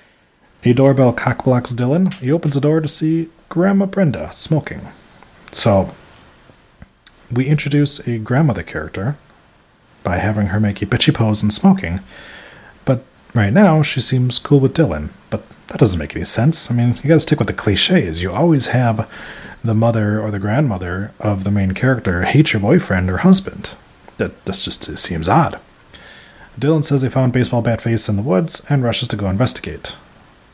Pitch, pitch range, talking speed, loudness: 125 Hz, 105-150 Hz, 175 wpm, -16 LUFS